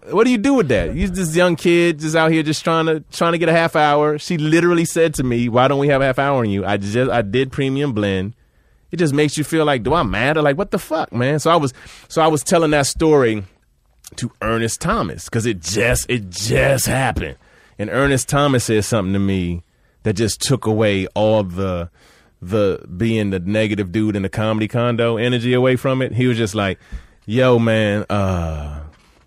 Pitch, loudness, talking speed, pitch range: 120 Hz, -17 LUFS, 220 wpm, 105-150 Hz